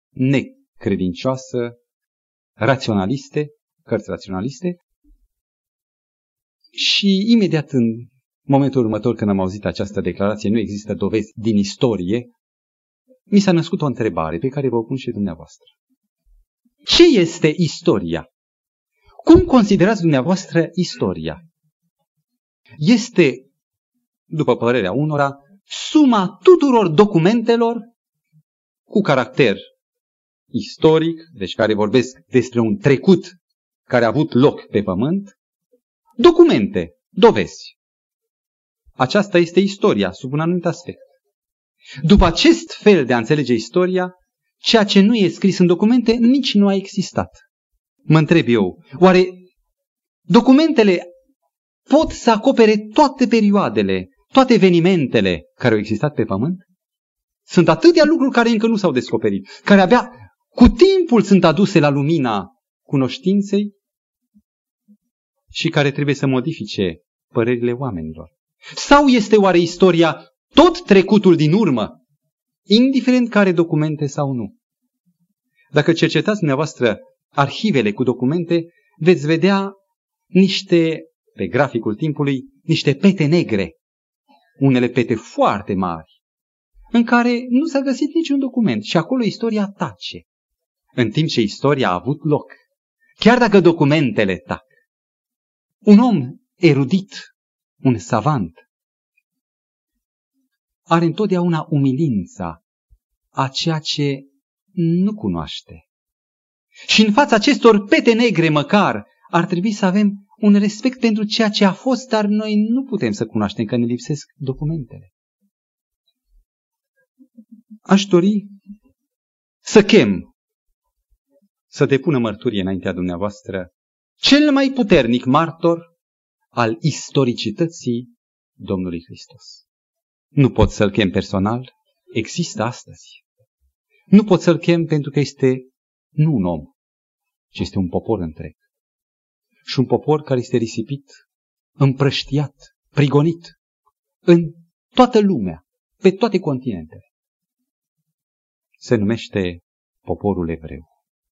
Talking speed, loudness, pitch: 110 wpm, -16 LUFS, 170 Hz